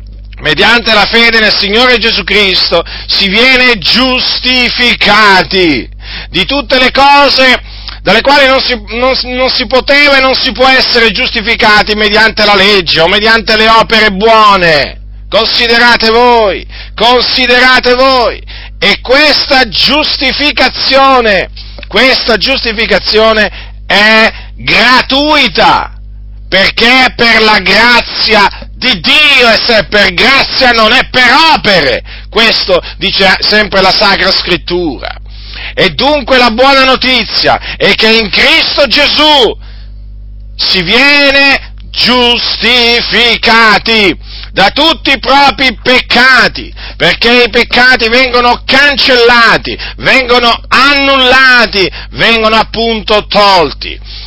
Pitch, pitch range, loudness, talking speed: 235 Hz, 210-260 Hz, -5 LUFS, 105 wpm